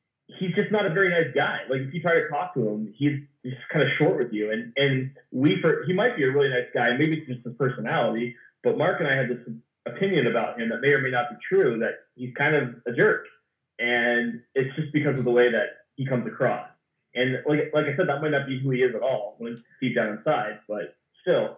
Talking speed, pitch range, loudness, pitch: 255 wpm, 120-150 Hz, -25 LUFS, 135 Hz